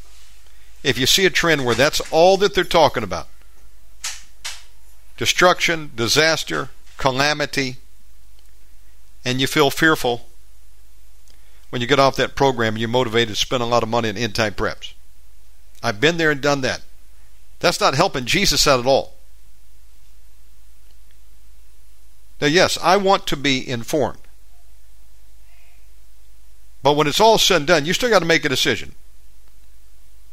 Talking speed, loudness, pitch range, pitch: 140 wpm, -18 LUFS, 95-150 Hz, 120 Hz